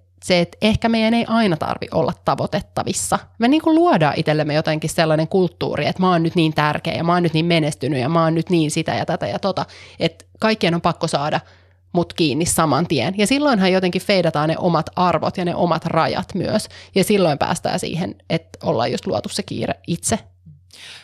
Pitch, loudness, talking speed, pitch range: 165 Hz, -19 LUFS, 200 wpm, 155-180 Hz